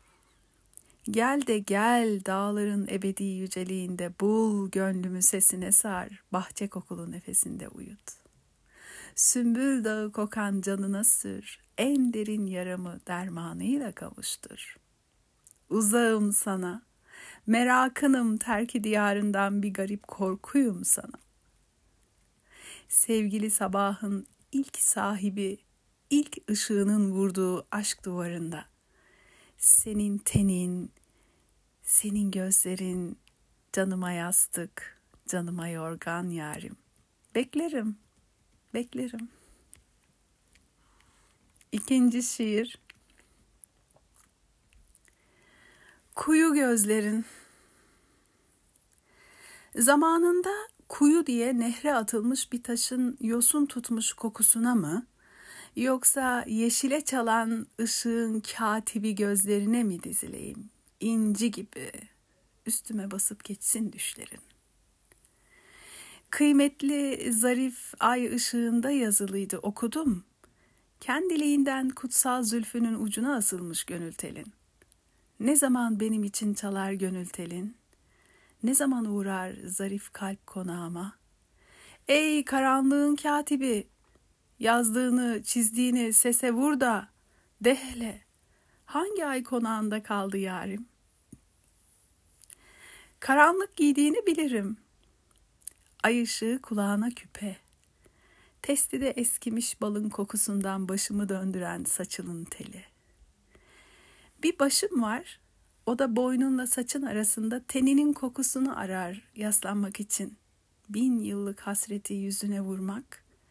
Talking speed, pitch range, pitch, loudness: 80 wpm, 200-250 Hz, 220 Hz, -26 LUFS